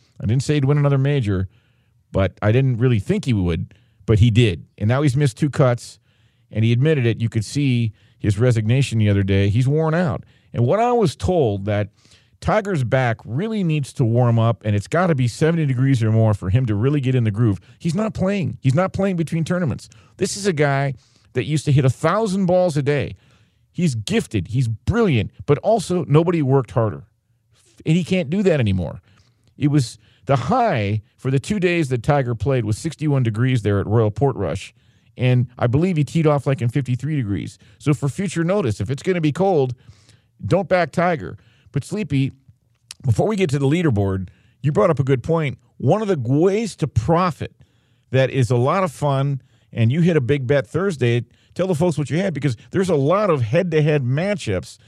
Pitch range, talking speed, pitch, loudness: 115-155 Hz, 210 wpm, 130 Hz, -20 LUFS